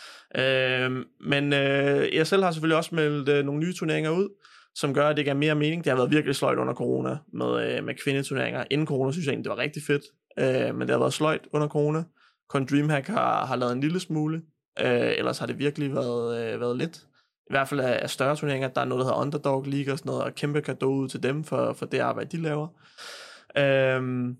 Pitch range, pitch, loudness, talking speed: 135-155 Hz, 140 Hz, -26 LUFS, 235 wpm